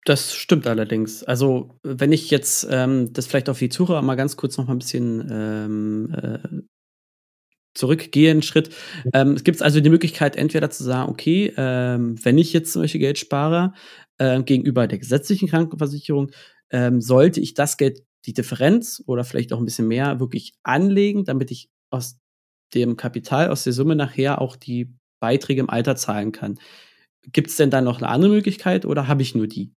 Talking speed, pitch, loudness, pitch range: 180 wpm, 135 Hz, -20 LUFS, 125-155 Hz